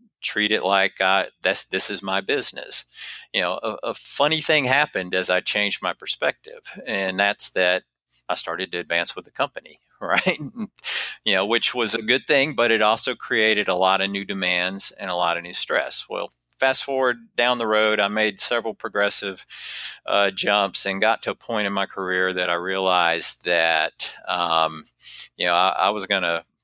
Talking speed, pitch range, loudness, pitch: 195 wpm, 90-115 Hz, -22 LUFS, 100 Hz